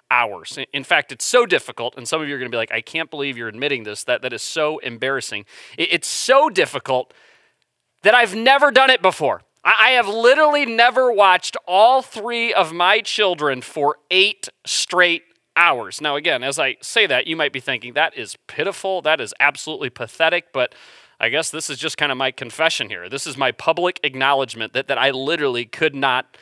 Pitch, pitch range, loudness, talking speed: 155 Hz, 135-195 Hz, -18 LUFS, 200 wpm